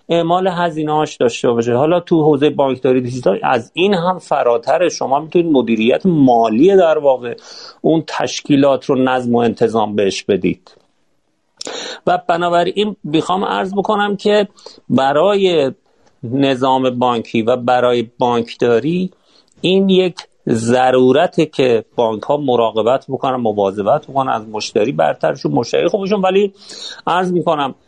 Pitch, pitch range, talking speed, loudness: 140 Hz, 125-180 Hz, 125 wpm, -15 LUFS